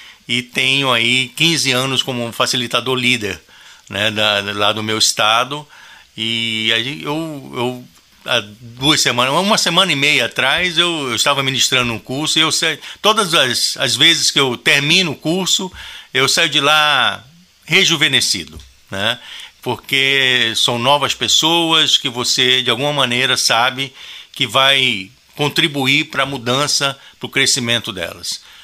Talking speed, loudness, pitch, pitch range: 140 wpm, -14 LUFS, 135 Hz, 120-150 Hz